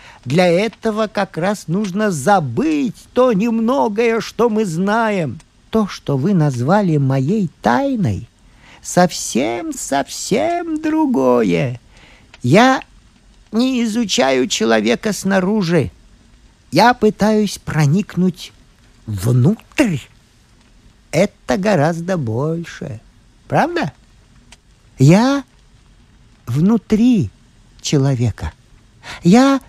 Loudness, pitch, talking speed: -16 LUFS, 180 Hz, 75 wpm